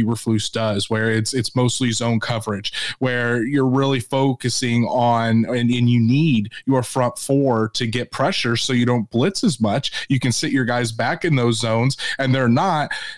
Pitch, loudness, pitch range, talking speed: 120 Hz, -19 LUFS, 115-130 Hz, 185 wpm